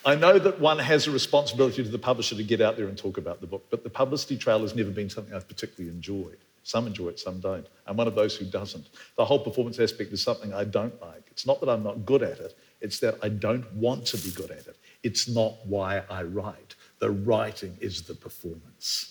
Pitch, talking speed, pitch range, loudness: 110 Hz, 245 wpm, 100-120 Hz, -27 LUFS